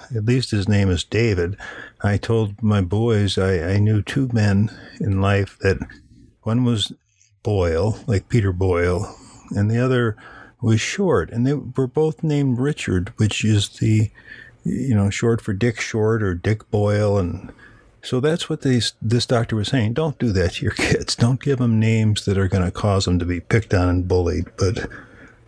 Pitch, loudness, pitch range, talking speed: 110 Hz, -20 LUFS, 100-120 Hz, 185 wpm